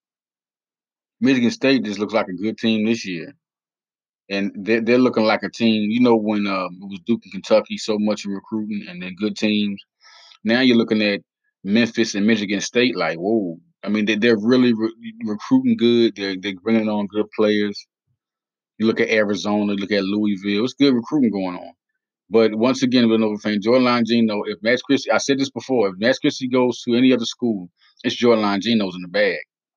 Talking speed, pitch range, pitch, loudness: 200 wpm, 105-120 Hz, 110 Hz, -19 LUFS